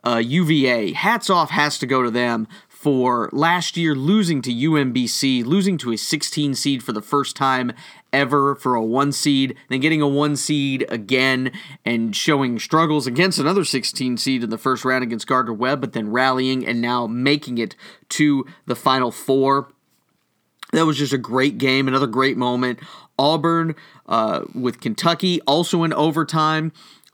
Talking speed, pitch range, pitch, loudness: 170 wpm, 125-155 Hz, 135 Hz, -19 LUFS